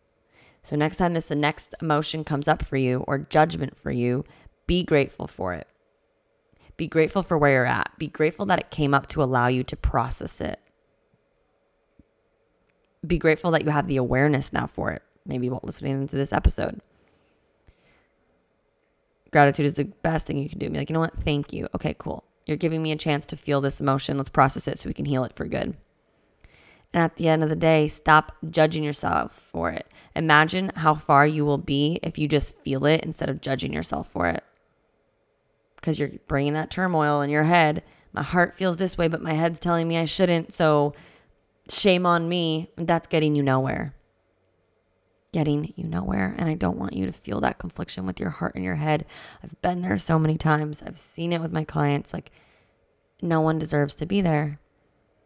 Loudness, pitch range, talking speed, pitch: -24 LUFS, 140-165 Hz, 200 wpm, 150 Hz